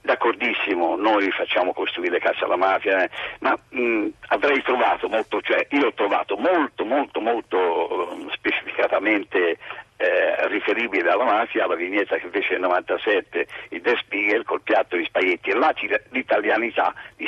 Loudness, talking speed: -22 LUFS, 145 wpm